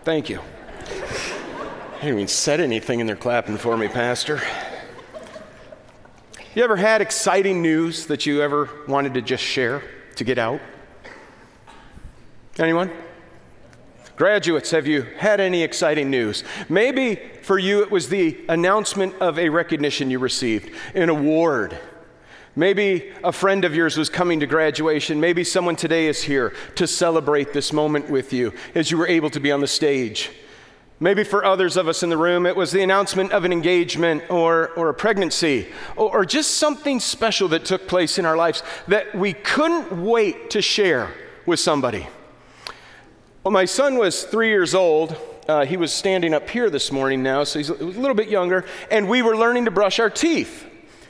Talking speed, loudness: 175 wpm, -20 LUFS